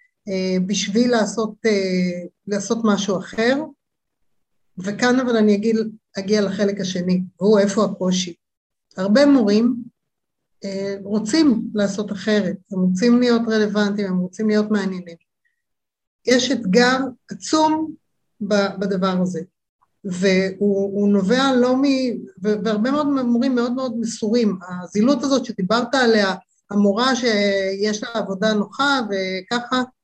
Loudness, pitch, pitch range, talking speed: -19 LUFS, 210 Hz, 195-240 Hz, 115 wpm